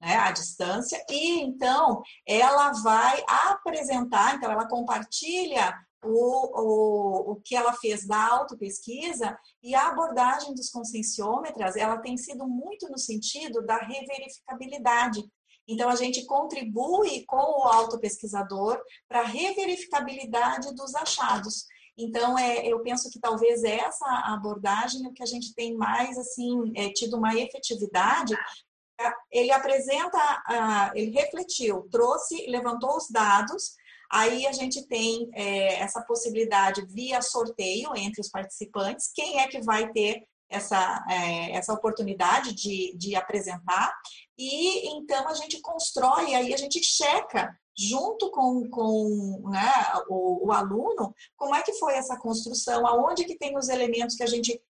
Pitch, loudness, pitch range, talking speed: 240 Hz, -26 LUFS, 220-275 Hz, 135 wpm